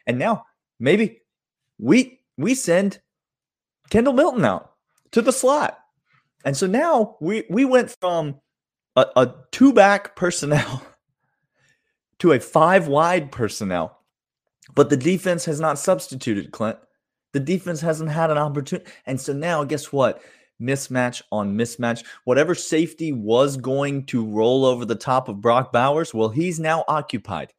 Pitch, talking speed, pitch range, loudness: 150 Hz, 140 wpm, 130-180 Hz, -21 LUFS